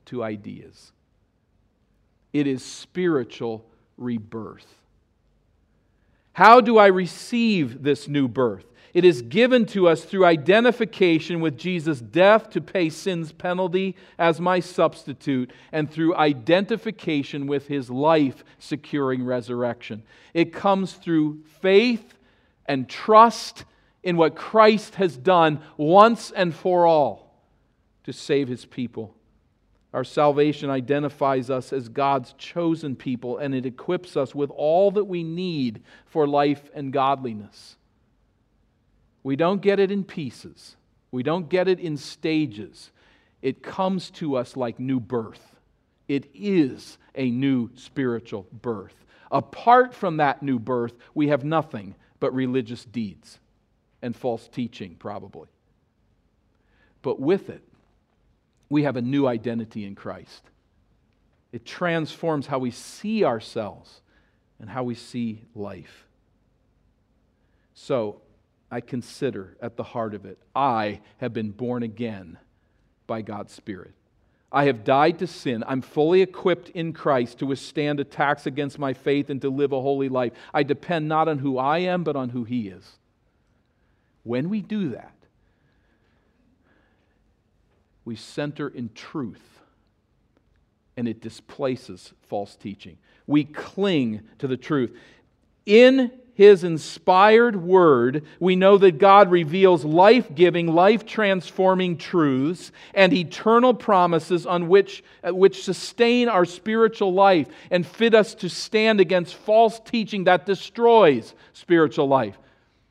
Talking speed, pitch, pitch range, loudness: 130 wpm, 145 Hz, 120-180 Hz, -21 LUFS